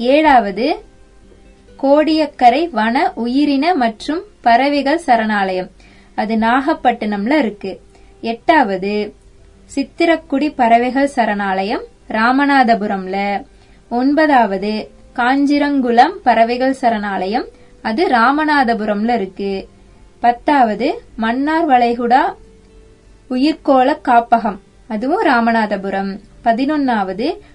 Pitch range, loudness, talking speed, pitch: 215-285 Hz, -15 LUFS, 65 wpm, 240 Hz